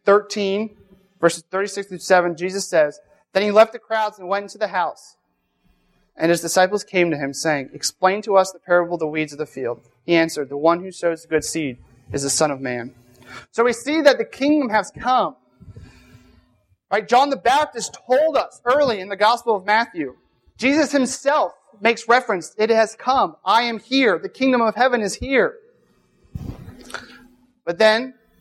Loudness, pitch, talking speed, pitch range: -20 LUFS, 200 Hz, 185 wpm, 165-240 Hz